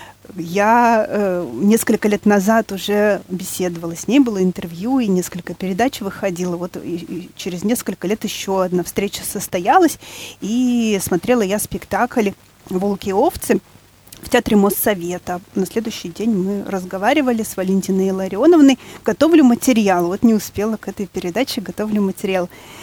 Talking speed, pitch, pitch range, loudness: 140 wpm, 200 Hz, 185-225 Hz, -18 LUFS